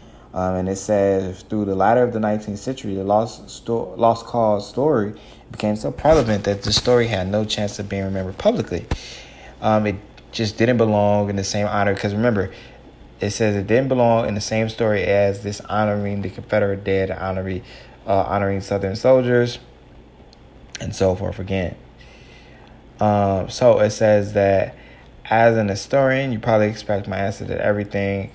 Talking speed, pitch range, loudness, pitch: 170 wpm, 95-110 Hz, -20 LUFS, 105 Hz